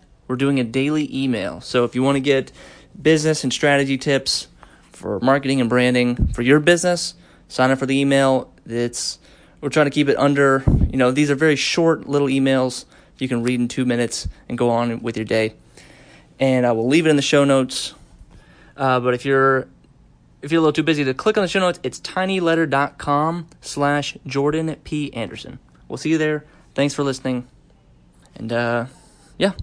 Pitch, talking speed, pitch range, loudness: 135 Hz, 190 wpm, 125-150 Hz, -19 LUFS